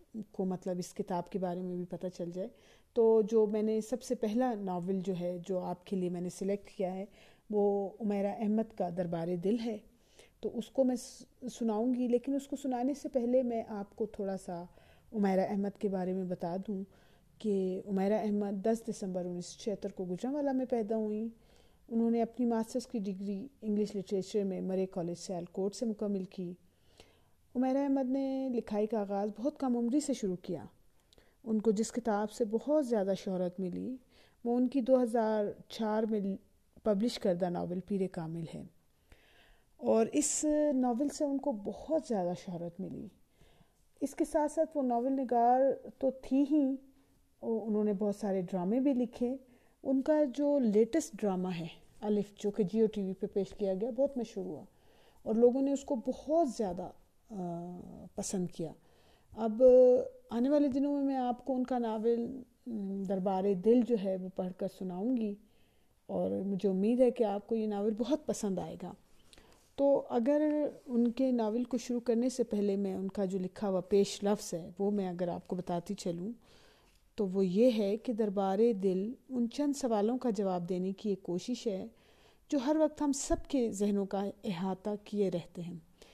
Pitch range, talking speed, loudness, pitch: 195-250 Hz, 185 wpm, -33 LUFS, 215 Hz